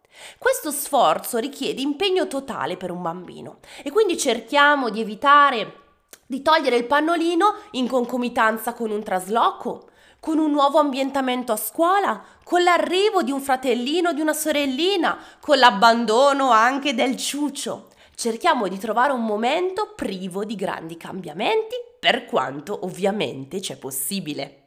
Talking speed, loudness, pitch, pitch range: 135 wpm, -21 LUFS, 260 Hz, 220-310 Hz